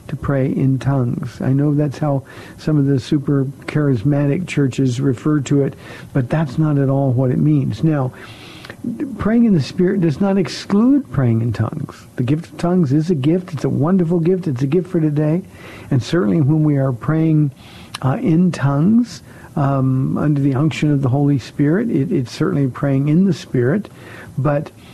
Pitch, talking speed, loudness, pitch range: 150 Hz, 180 wpm, -17 LUFS, 135-165 Hz